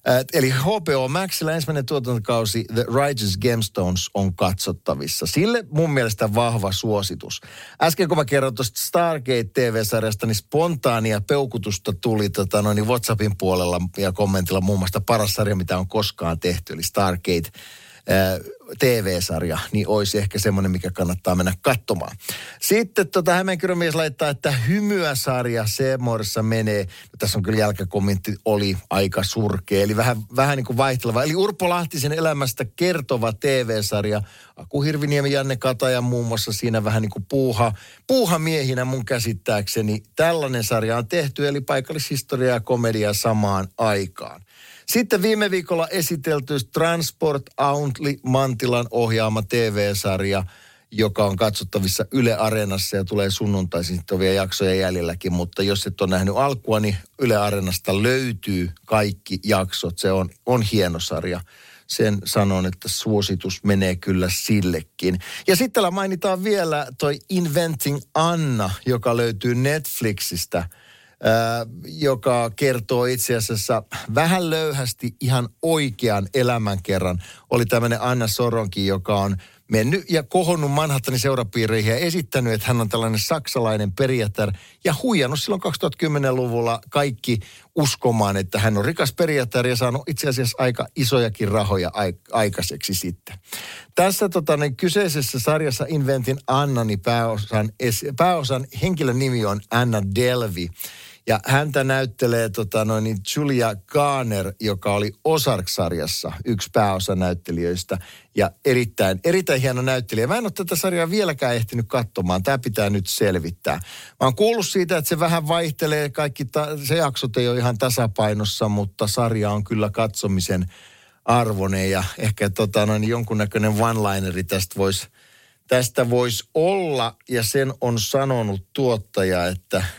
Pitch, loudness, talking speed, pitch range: 115 Hz, -21 LUFS, 135 wpm, 100-140 Hz